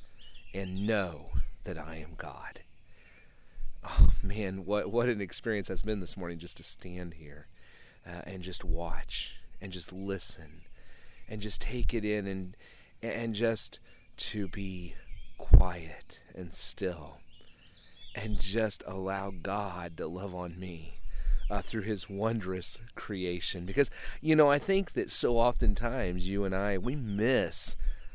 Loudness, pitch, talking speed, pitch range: -33 LUFS, 95 Hz, 140 wpm, 90-105 Hz